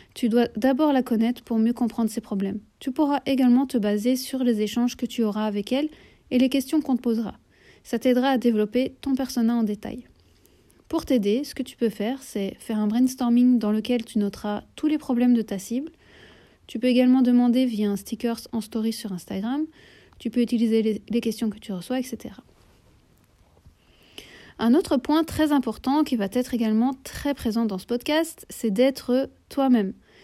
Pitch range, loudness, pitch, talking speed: 225-260 Hz, -24 LUFS, 240 Hz, 190 wpm